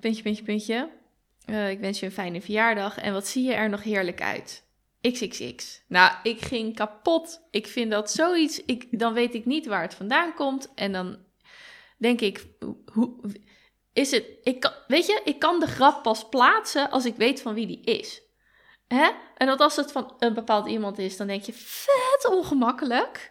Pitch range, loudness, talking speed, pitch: 210-295 Hz, -25 LUFS, 195 wpm, 240 Hz